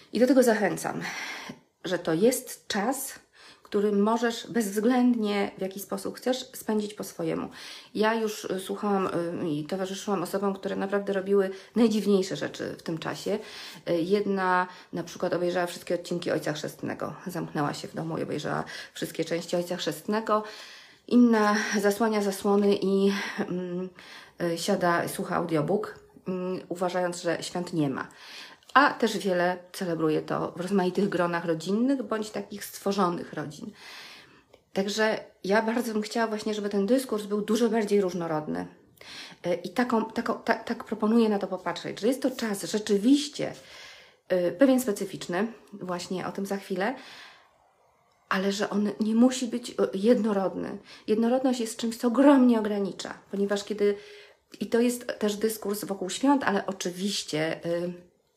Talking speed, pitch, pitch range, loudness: 140 wpm, 200 Hz, 180-225 Hz, -27 LUFS